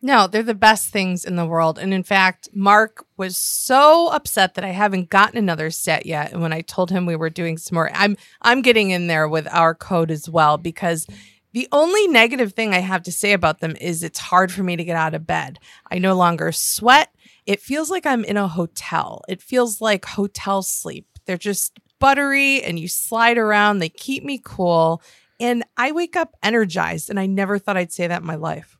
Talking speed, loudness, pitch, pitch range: 220 wpm, -18 LUFS, 190 Hz, 170-225 Hz